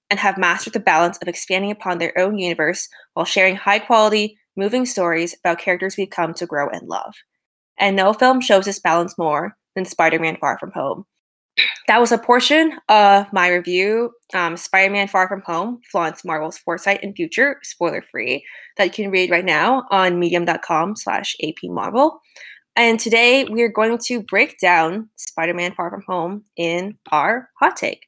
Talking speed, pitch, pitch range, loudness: 165 wpm, 190 Hz, 175-220 Hz, -18 LUFS